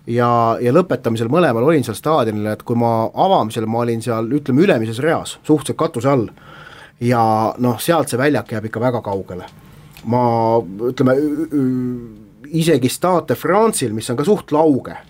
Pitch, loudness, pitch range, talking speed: 120 Hz, -17 LUFS, 115-150 Hz, 160 wpm